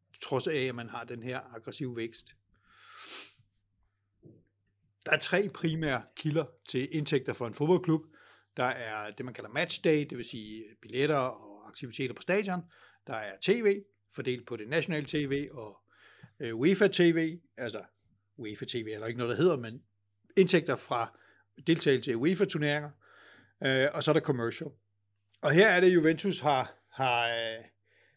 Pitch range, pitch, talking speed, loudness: 115-160 Hz, 130 Hz, 150 wpm, -30 LUFS